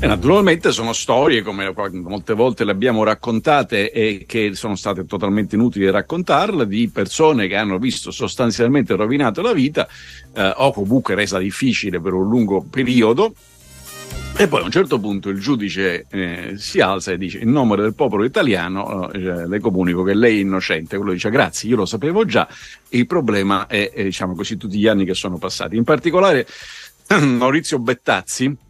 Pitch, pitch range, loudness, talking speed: 105 Hz, 95-120 Hz, -18 LUFS, 175 wpm